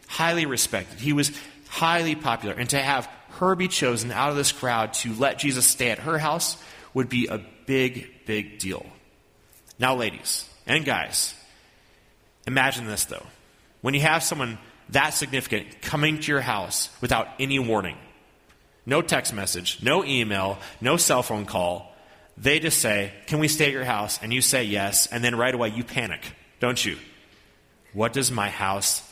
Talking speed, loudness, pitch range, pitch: 170 wpm, -24 LUFS, 105-140 Hz, 125 Hz